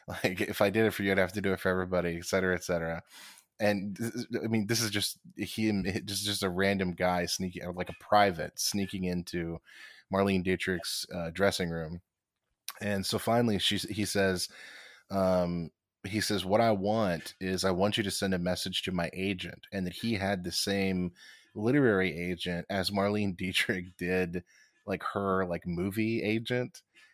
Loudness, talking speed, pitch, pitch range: -31 LUFS, 180 wpm, 95 Hz, 90-105 Hz